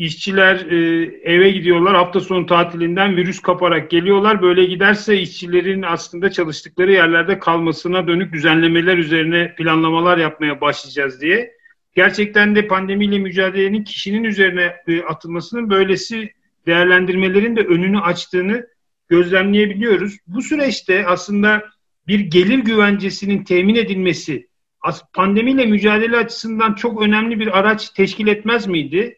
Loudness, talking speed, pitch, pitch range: -15 LUFS, 110 wpm, 190 Hz, 175-210 Hz